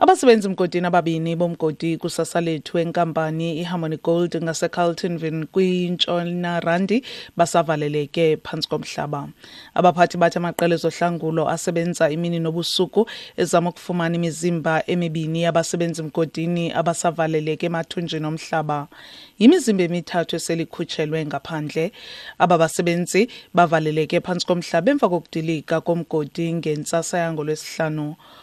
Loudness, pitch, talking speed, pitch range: -21 LUFS, 170 Hz, 90 wpm, 160-175 Hz